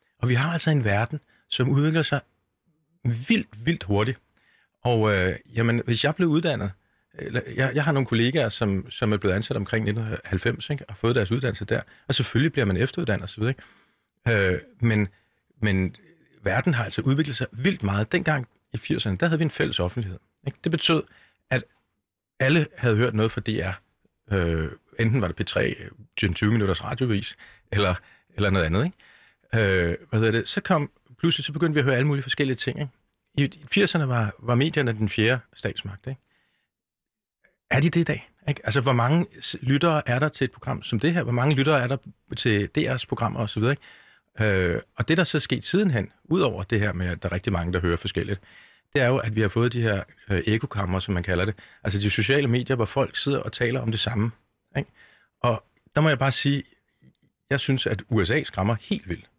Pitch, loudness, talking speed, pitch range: 120 Hz, -25 LUFS, 200 wpm, 105-140 Hz